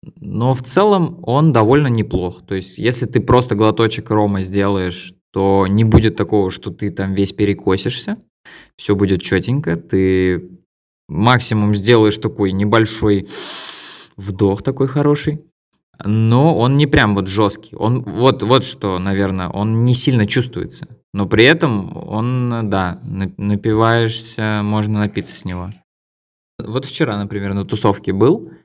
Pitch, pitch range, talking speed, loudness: 105 Hz, 95-120 Hz, 135 wpm, -16 LUFS